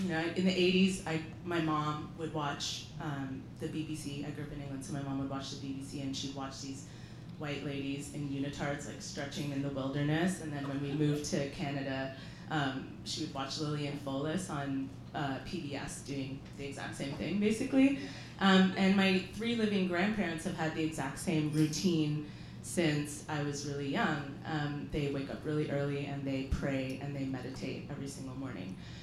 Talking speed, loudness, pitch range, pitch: 190 wpm, -35 LUFS, 135-160 Hz, 145 Hz